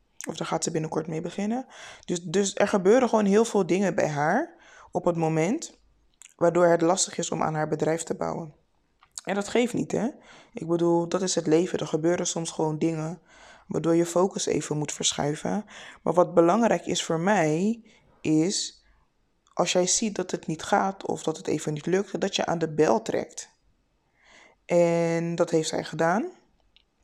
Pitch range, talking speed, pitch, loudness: 160-200 Hz, 185 wpm, 170 Hz, -25 LUFS